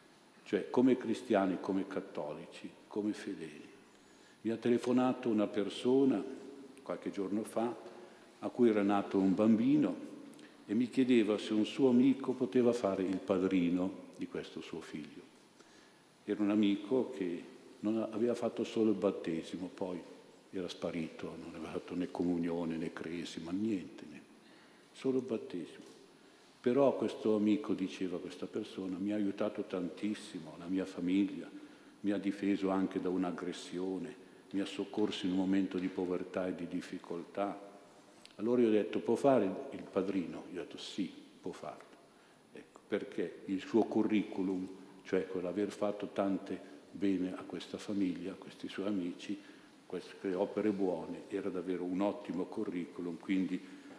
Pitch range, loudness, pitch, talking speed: 95-115 Hz, -35 LUFS, 100 Hz, 145 wpm